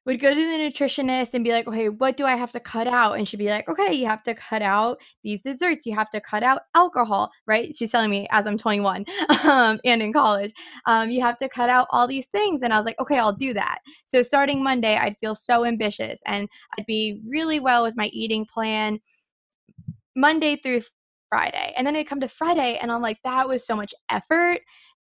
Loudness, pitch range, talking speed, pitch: -22 LUFS, 215-275 Hz, 230 wpm, 240 Hz